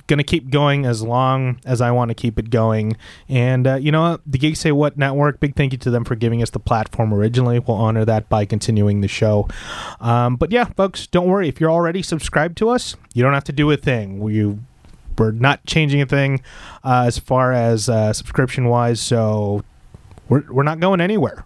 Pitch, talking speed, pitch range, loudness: 125 Hz, 220 wpm, 110-145 Hz, -18 LUFS